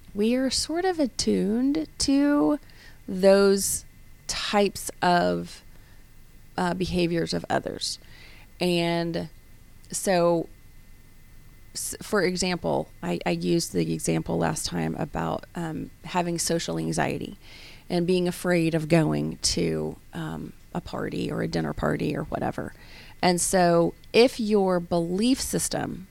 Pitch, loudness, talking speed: 170 Hz, -25 LUFS, 115 wpm